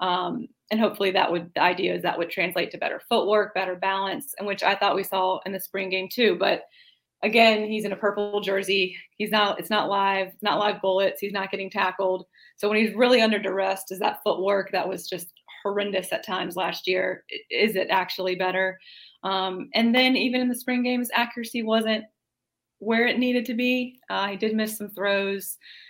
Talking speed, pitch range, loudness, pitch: 205 wpm, 190-220 Hz, -24 LUFS, 195 Hz